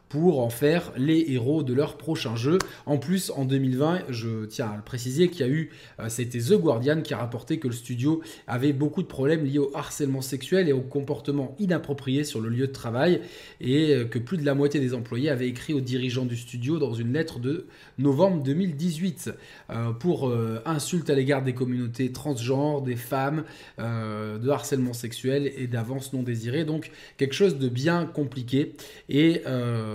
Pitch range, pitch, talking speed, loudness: 125-155 Hz, 140 Hz, 190 wpm, -26 LUFS